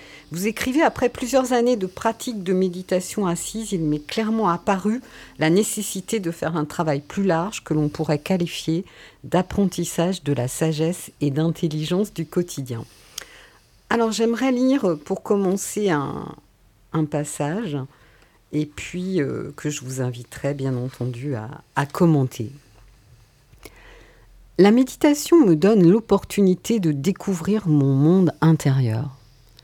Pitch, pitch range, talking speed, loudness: 165 Hz, 140-200 Hz, 130 wpm, -22 LUFS